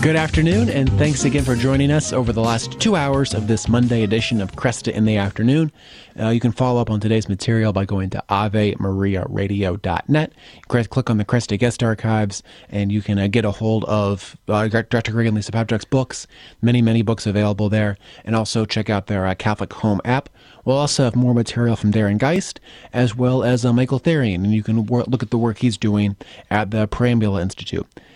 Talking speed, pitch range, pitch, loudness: 205 wpm, 105-125 Hz, 115 Hz, -19 LUFS